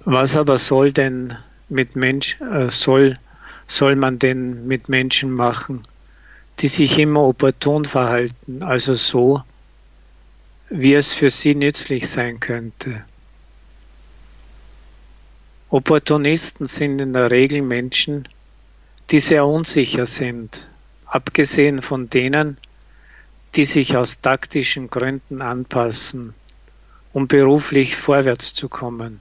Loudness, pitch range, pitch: -17 LUFS, 120-140 Hz, 130 Hz